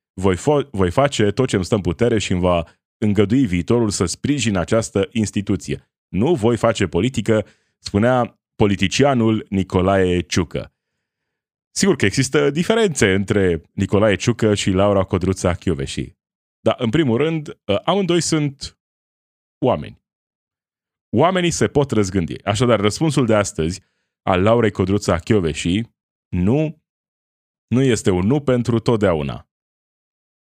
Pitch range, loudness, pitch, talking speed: 95-120 Hz, -19 LUFS, 105 Hz, 125 wpm